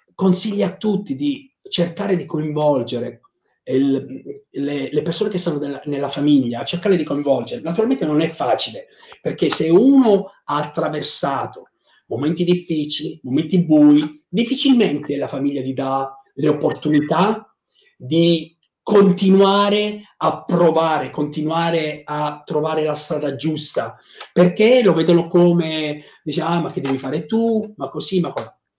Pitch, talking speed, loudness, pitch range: 160 Hz, 135 wpm, -18 LUFS, 150-195 Hz